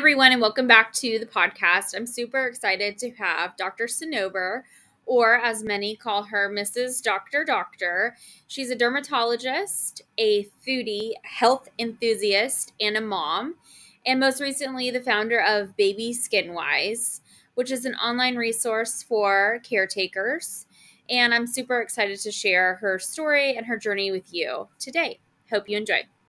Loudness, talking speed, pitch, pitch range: -23 LUFS, 150 wpm, 230 Hz, 205-250 Hz